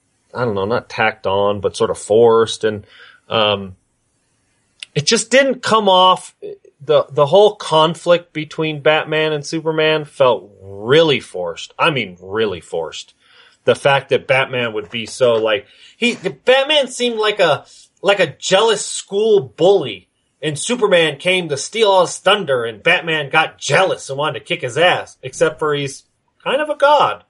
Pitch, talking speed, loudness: 195 Hz, 165 wpm, -16 LUFS